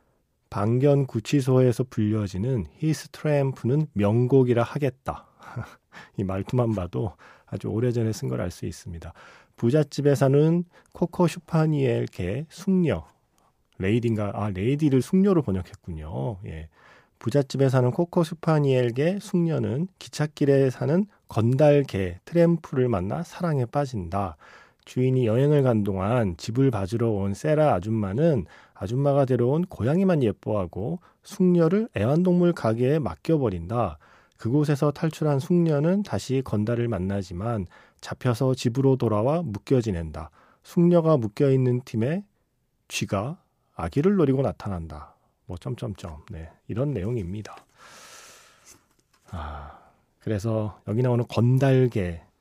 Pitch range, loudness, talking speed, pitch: 105-150 Hz, -24 LUFS, 280 characters per minute, 125 Hz